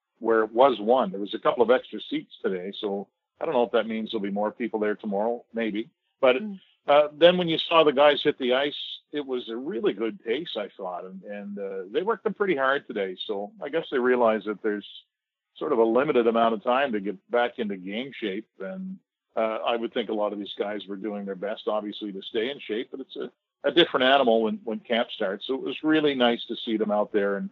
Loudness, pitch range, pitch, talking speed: -26 LUFS, 105-140 Hz, 115 Hz, 250 wpm